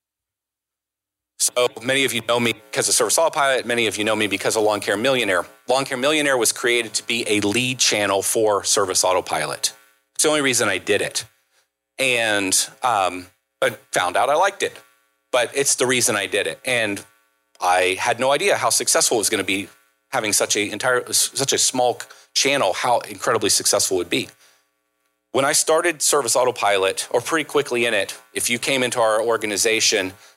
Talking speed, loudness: 190 wpm, -19 LUFS